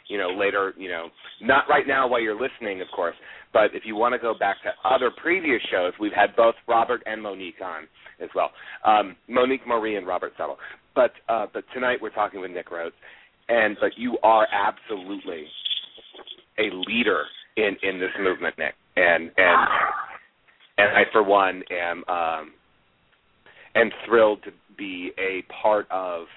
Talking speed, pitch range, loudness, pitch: 170 wpm, 95-115 Hz, -23 LUFS, 100 Hz